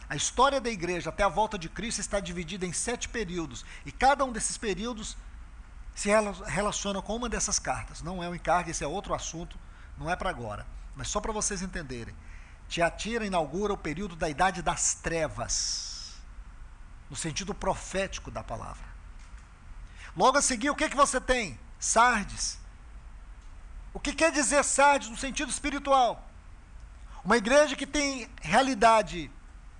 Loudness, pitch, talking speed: -28 LUFS, 180 Hz, 155 wpm